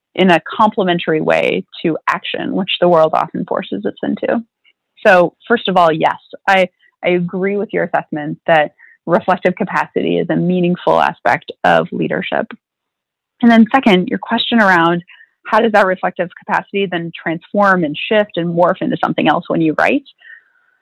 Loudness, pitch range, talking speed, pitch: -15 LUFS, 175-225 Hz, 160 wpm, 190 Hz